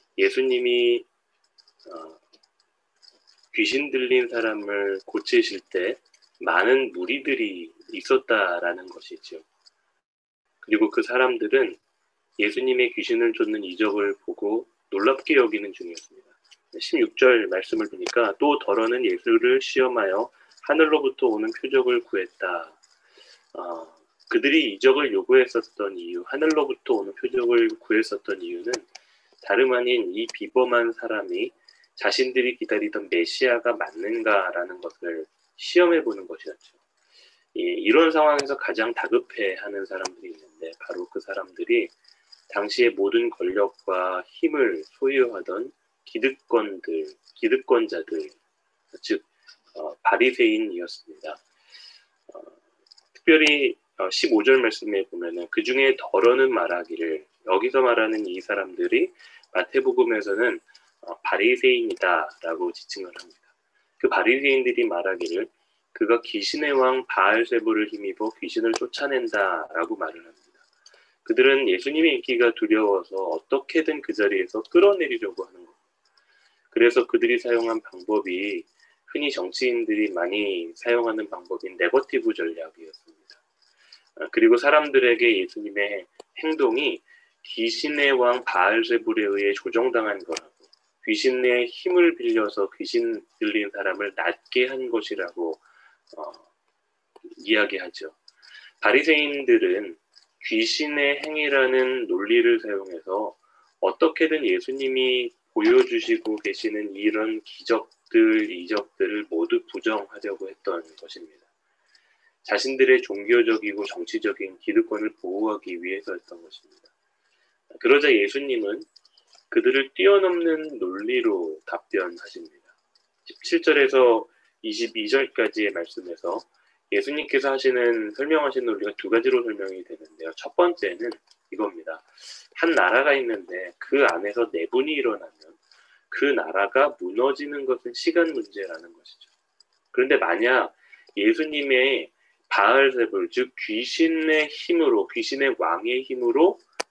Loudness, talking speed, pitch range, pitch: -23 LUFS, 275 characters per minute, 335-390 Hz, 365 Hz